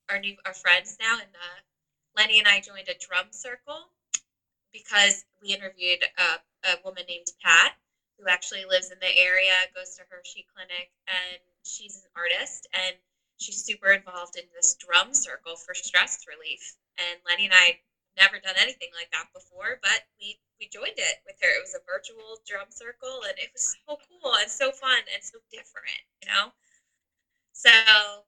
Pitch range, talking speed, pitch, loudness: 180-240 Hz, 175 wpm, 195 Hz, -22 LUFS